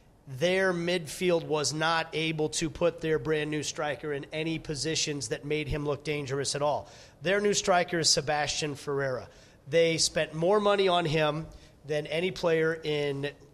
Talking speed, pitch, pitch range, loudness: 165 wpm, 155 Hz, 150-165 Hz, -28 LUFS